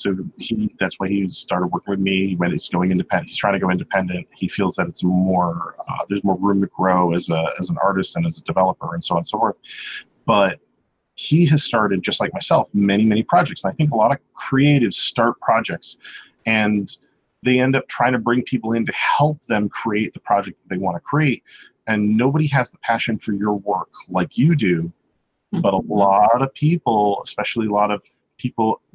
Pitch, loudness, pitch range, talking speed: 105 Hz, -19 LUFS, 95-125 Hz, 215 wpm